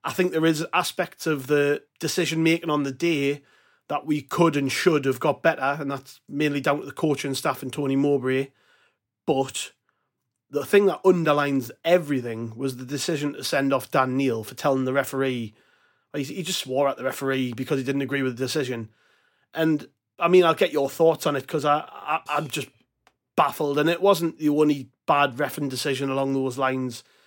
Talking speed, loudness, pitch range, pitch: 195 wpm, -24 LUFS, 135-155 Hz, 140 Hz